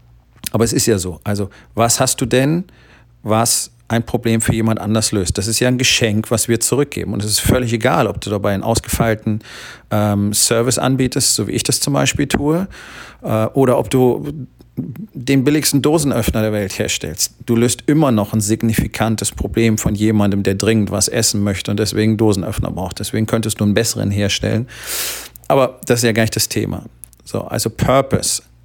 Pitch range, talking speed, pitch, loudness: 105-125 Hz, 190 wpm, 115 Hz, -16 LUFS